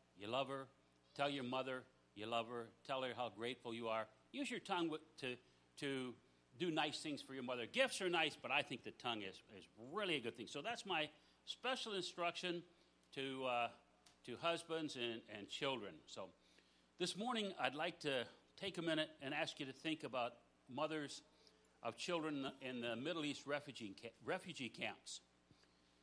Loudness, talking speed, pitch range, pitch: -45 LUFS, 180 wpm, 115-160 Hz, 135 Hz